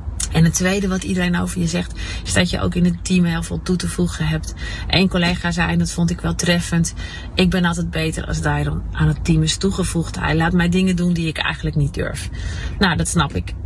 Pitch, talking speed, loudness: 165 Hz, 240 wpm, -19 LUFS